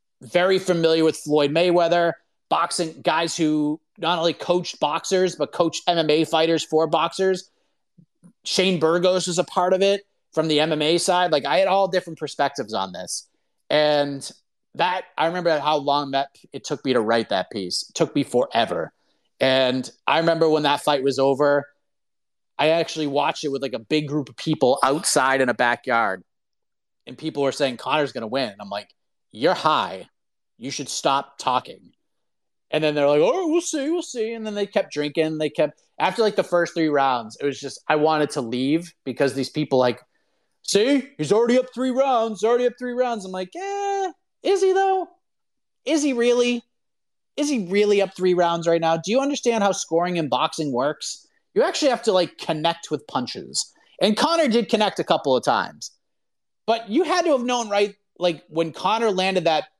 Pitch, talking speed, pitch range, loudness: 170 Hz, 195 wpm, 150-210 Hz, -22 LUFS